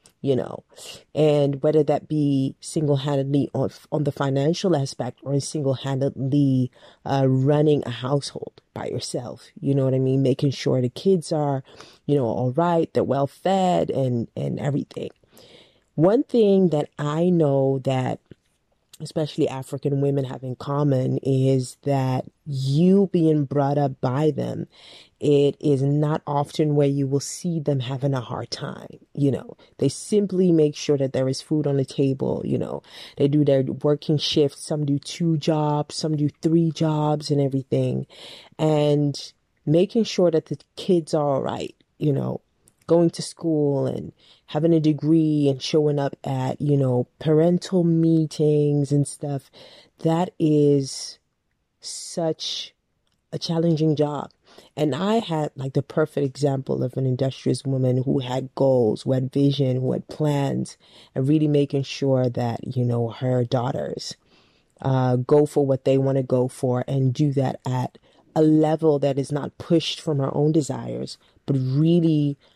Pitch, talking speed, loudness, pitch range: 145 Hz, 160 wpm, -22 LUFS, 135-155 Hz